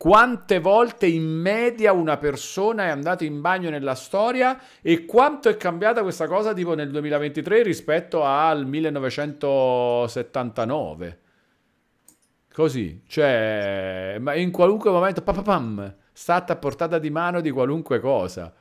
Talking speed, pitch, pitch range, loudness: 125 wpm, 160 Hz, 130-195 Hz, -22 LUFS